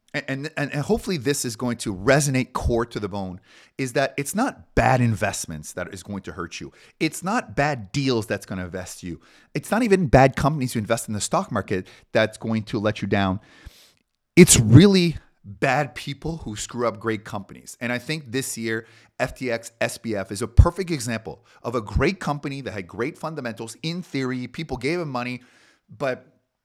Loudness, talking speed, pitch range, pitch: -23 LUFS, 195 wpm, 105-145 Hz, 120 Hz